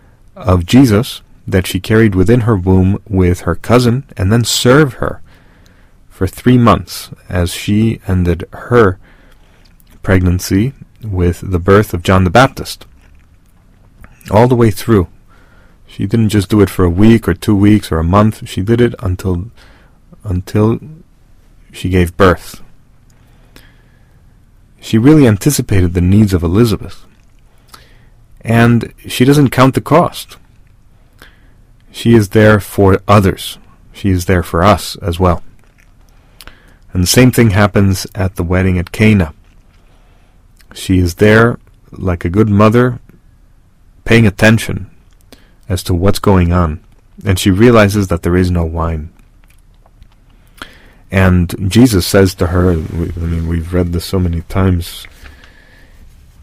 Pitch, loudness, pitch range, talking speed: 100 Hz, -12 LUFS, 90-110 Hz, 135 wpm